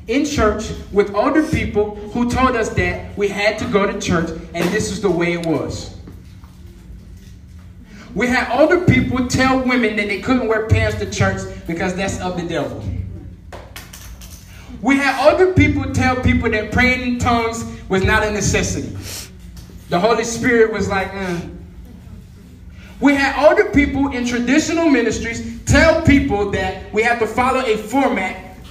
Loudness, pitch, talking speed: -17 LUFS, 205 Hz, 160 wpm